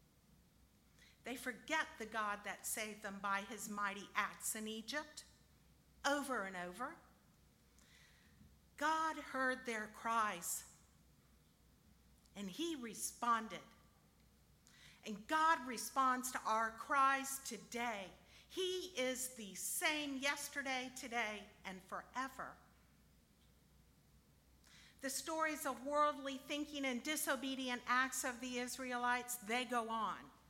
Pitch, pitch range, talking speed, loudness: 245 Hz, 210-275 Hz, 100 wpm, -41 LUFS